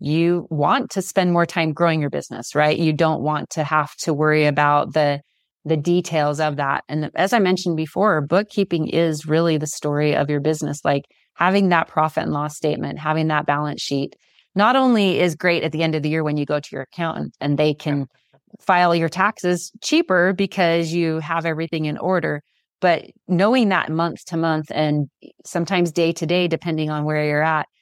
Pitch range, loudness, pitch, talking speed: 150-175 Hz, -20 LUFS, 160 Hz, 200 wpm